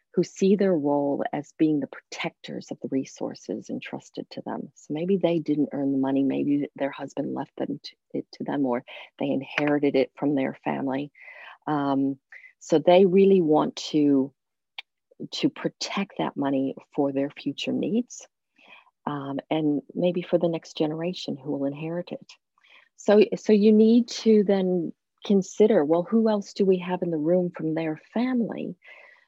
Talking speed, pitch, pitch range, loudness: 165 wpm, 165 Hz, 145-195 Hz, -25 LUFS